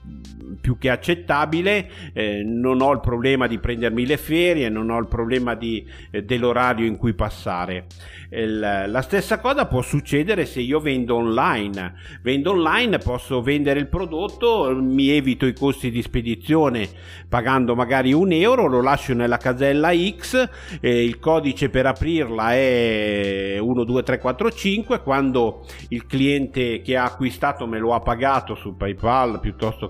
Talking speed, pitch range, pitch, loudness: 145 wpm, 115-140 Hz, 125 Hz, -21 LUFS